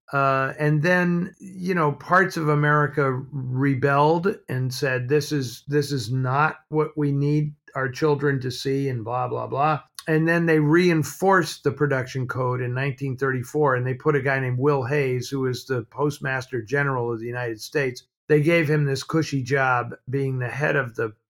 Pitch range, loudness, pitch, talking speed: 130-150 Hz, -23 LUFS, 140 Hz, 180 wpm